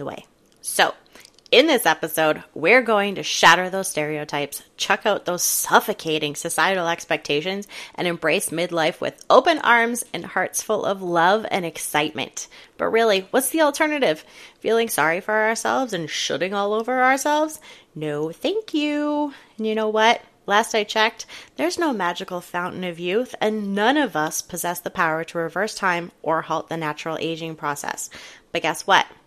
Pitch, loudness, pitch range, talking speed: 190 Hz, -21 LUFS, 165-230 Hz, 160 wpm